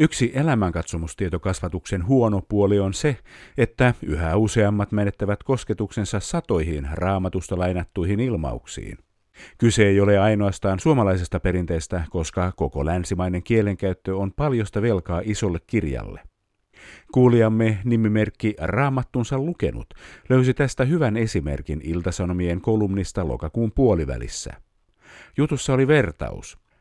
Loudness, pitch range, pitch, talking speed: -22 LUFS, 90-115 Hz, 100 Hz, 100 wpm